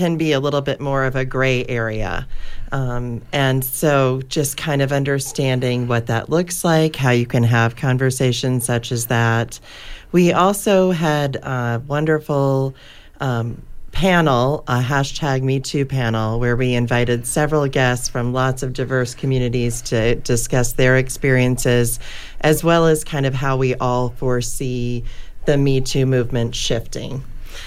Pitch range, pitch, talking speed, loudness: 120-140 Hz, 130 Hz, 150 wpm, -19 LUFS